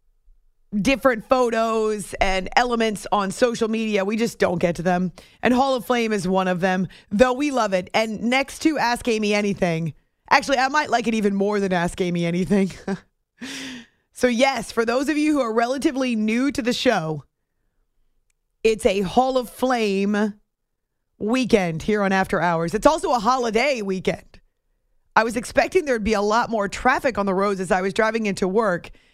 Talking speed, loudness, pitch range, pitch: 185 wpm, -21 LUFS, 195-250 Hz, 220 Hz